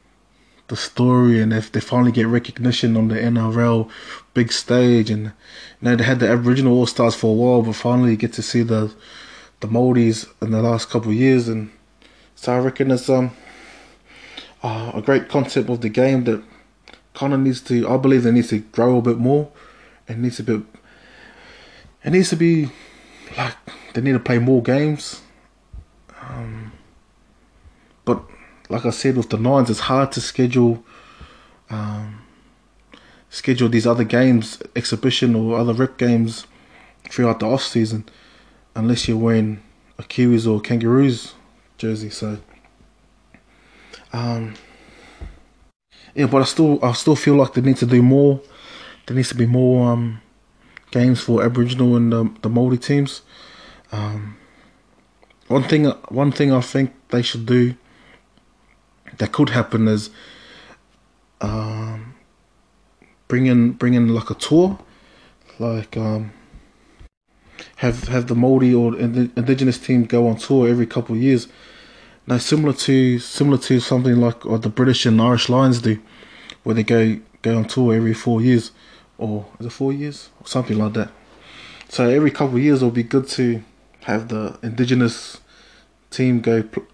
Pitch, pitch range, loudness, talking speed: 120 Hz, 115-130 Hz, -18 LUFS, 160 wpm